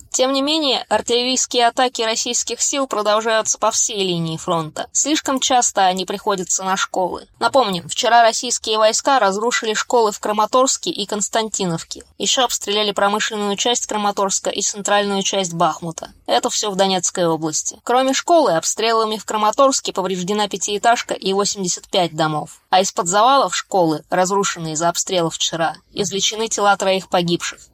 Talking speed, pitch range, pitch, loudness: 140 wpm, 190-235 Hz, 210 Hz, -18 LUFS